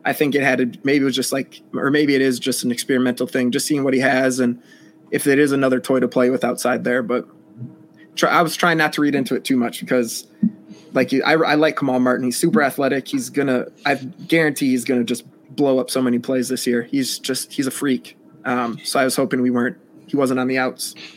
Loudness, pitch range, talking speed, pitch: -19 LUFS, 125-140 Hz, 255 wpm, 130 Hz